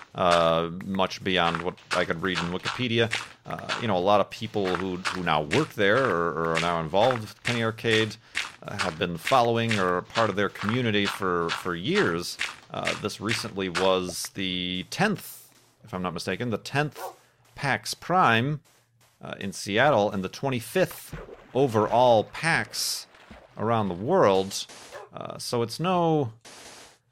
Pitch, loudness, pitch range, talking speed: 105 Hz, -26 LUFS, 90-115 Hz, 155 wpm